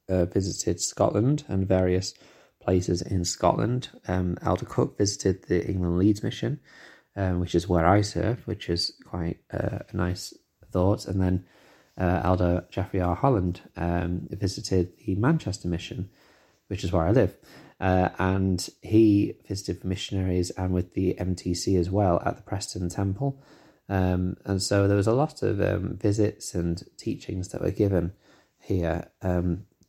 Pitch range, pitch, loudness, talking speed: 90-105 Hz, 95 Hz, -26 LUFS, 160 wpm